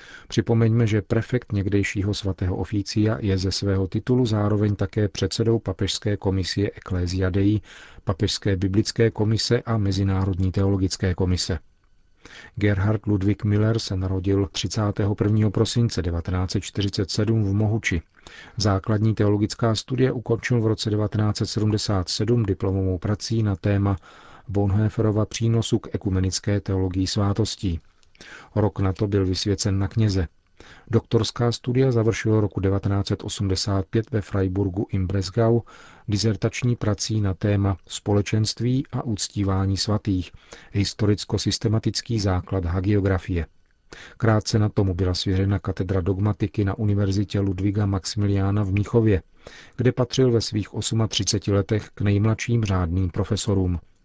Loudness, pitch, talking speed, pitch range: -23 LUFS, 105 Hz, 110 wpm, 95-110 Hz